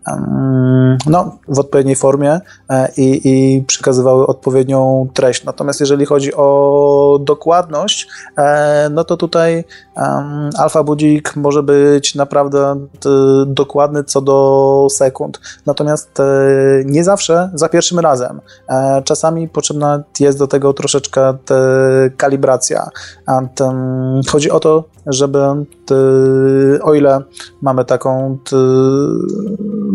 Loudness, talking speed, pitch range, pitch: -12 LUFS, 90 wpm, 135-150 Hz, 140 Hz